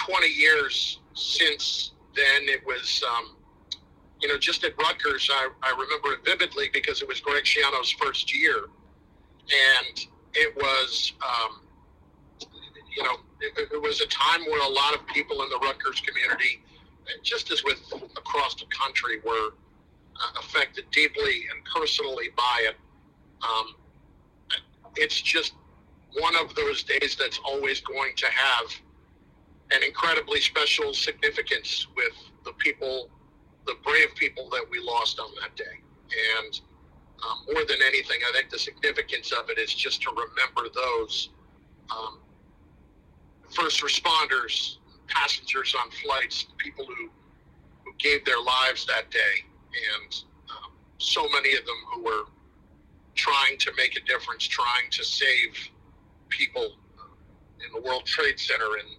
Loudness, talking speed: -24 LUFS, 140 wpm